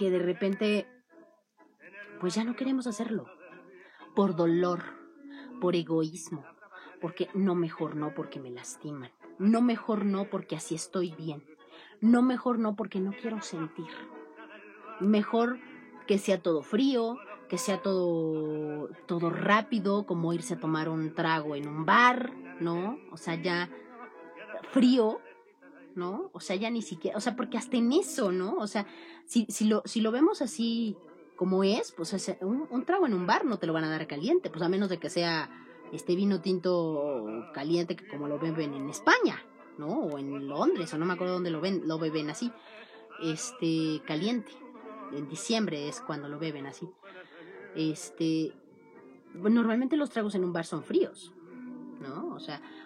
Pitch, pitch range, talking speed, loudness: 185 Hz, 165-230 Hz, 170 wpm, -30 LUFS